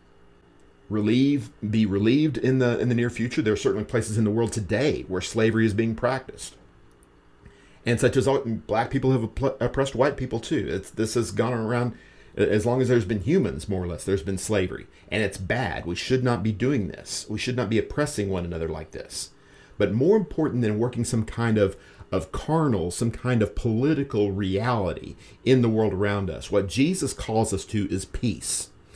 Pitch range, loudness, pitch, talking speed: 100-125 Hz, -25 LUFS, 110 Hz, 195 wpm